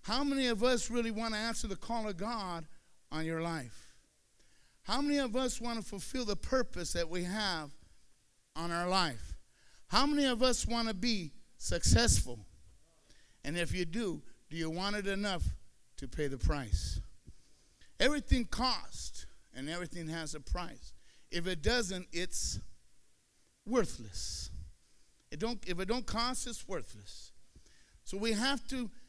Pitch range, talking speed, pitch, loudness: 150-235 Hz, 155 wpm, 185 Hz, -35 LUFS